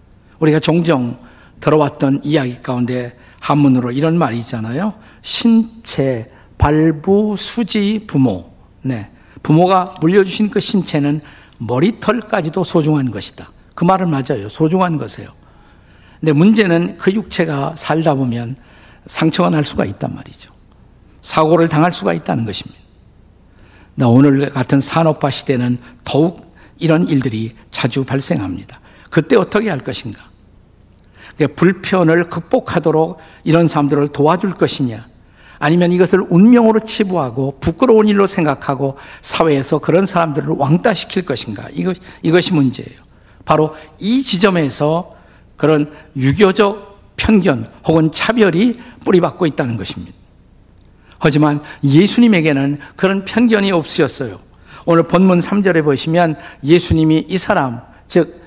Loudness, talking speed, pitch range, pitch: -15 LUFS, 290 characters per minute, 130-180 Hz, 155 Hz